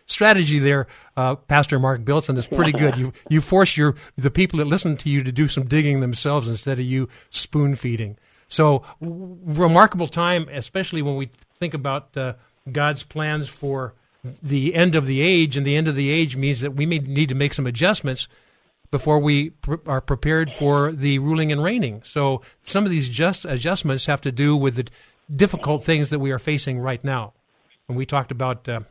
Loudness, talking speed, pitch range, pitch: -21 LUFS, 200 wpm, 135-155 Hz, 145 Hz